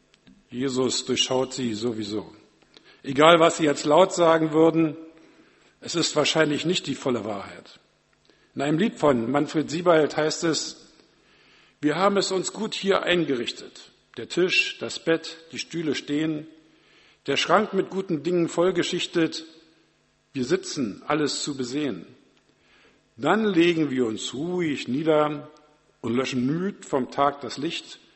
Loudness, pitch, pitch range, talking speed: -24 LUFS, 155 Hz, 135-170 Hz, 135 wpm